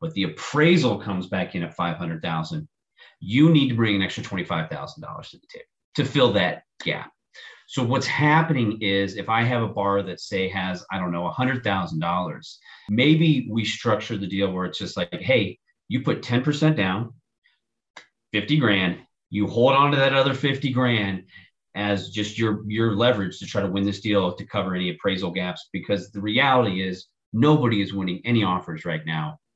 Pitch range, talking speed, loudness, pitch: 95-135 Hz, 180 wpm, -23 LUFS, 110 Hz